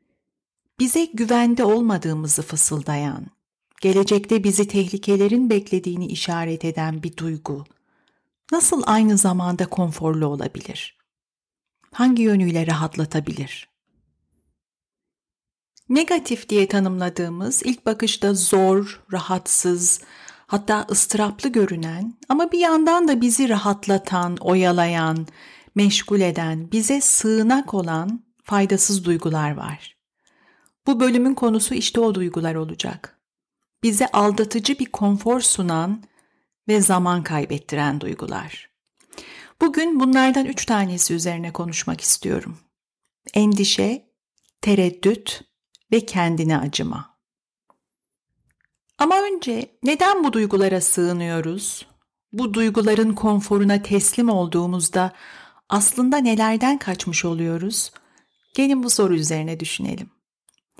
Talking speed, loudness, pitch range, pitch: 90 wpm, -20 LUFS, 175-235 Hz, 200 Hz